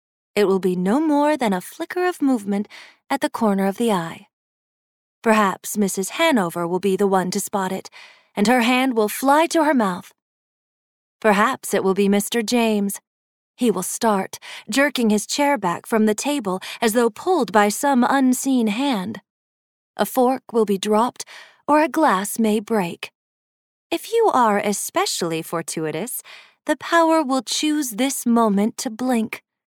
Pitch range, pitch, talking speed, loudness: 200-275 Hz, 225 Hz, 160 wpm, -20 LUFS